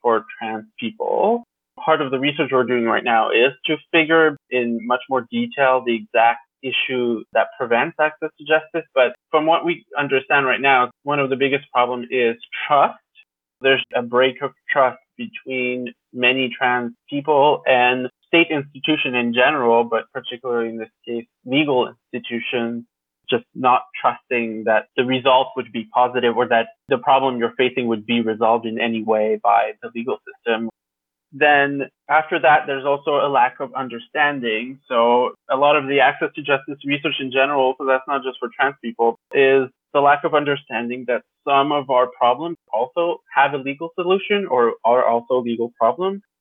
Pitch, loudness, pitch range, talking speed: 130 Hz, -19 LUFS, 120-145 Hz, 170 wpm